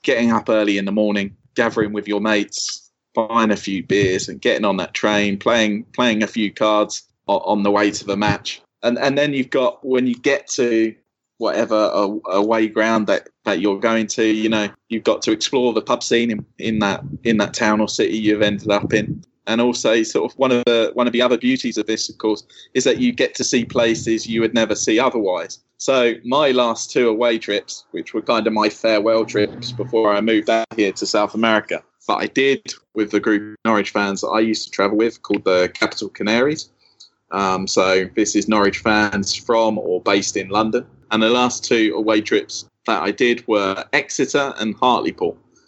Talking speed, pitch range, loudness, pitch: 210 wpm, 105-115 Hz, -19 LUFS, 110 Hz